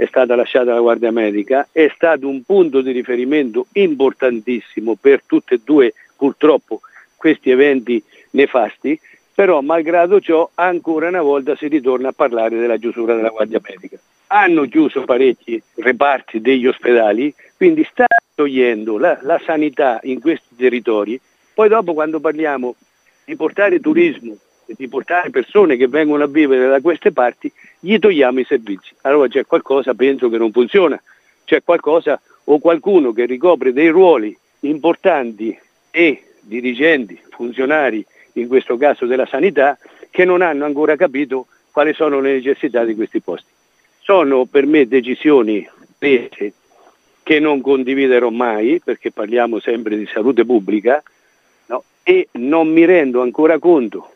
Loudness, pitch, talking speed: -15 LUFS, 155 Hz, 145 wpm